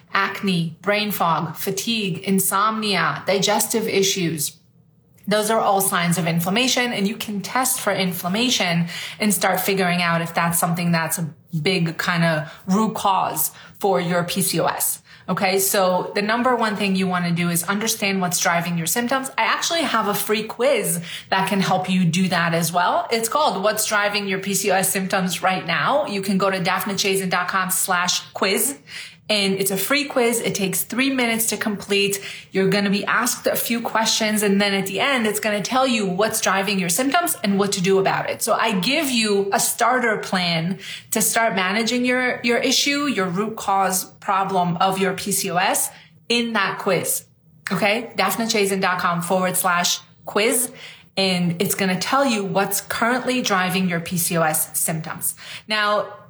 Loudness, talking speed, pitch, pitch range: -20 LUFS, 175 wpm, 195 Hz, 180-215 Hz